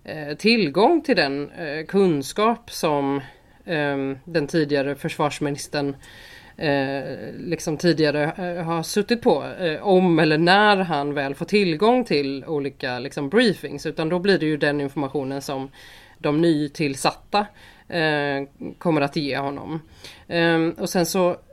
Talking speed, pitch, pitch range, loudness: 115 wpm, 155 Hz, 140-175 Hz, -22 LUFS